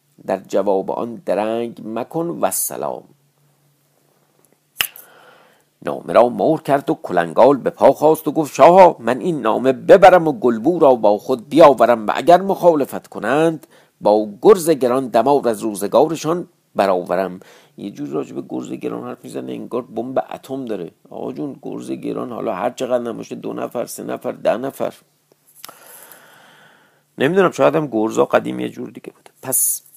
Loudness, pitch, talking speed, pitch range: -17 LUFS, 130 Hz, 150 wpm, 110-155 Hz